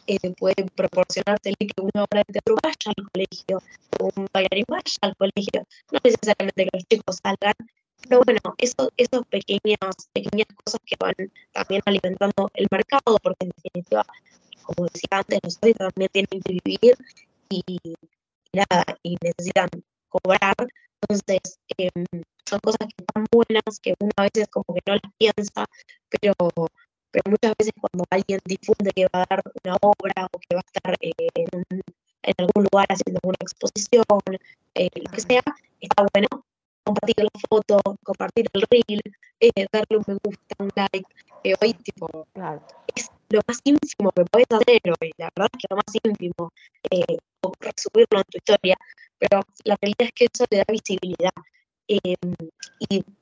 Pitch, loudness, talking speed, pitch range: 200 Hz, -22 LUFS, 160 wpm, 185-220 Hz